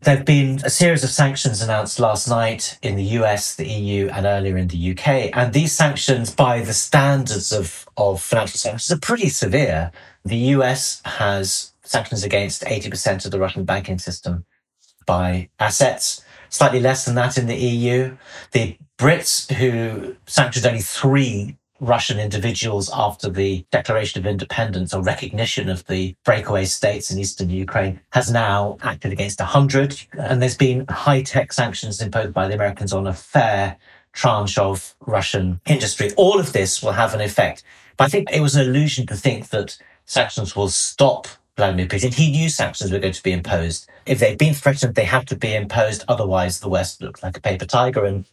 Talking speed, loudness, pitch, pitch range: 180 wpm, -19 LUFS, 110 Hz, 95-130 Hz